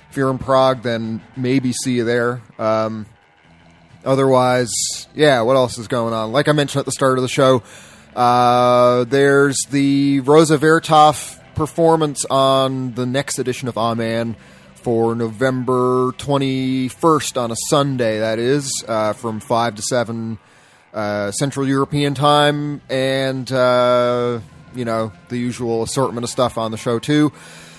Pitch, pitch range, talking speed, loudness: 125 Hz, 115-135 Hz, 150 wpm, -17 LUFS